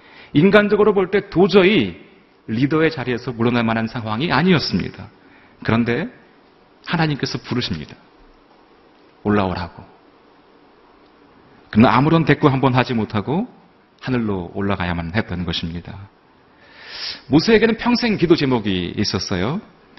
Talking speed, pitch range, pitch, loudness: 280 characters per minute, 100-170 Hz, 125 Hz, -18 LUFS